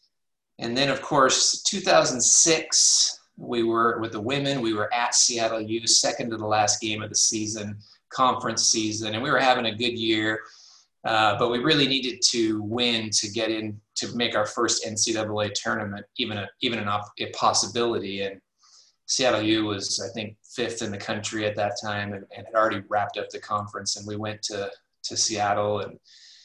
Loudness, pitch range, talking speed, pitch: -23 LUFS, 105-120 Hz, 190 wpm, 110 Hz